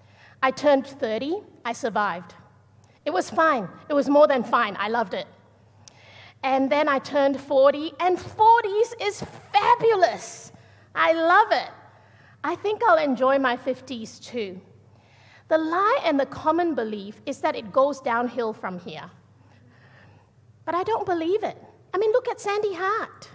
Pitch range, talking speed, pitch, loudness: 210-345 Hz, 150 wpm, 275 Hz, -23 LUFS